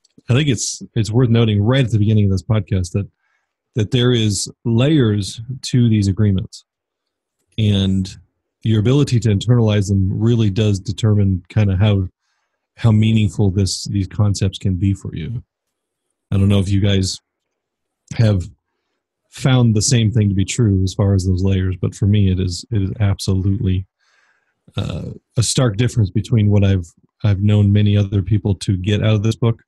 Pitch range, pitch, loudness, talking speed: 100-115 Hz, 105 Hz, -17 LUFS, 175 wpm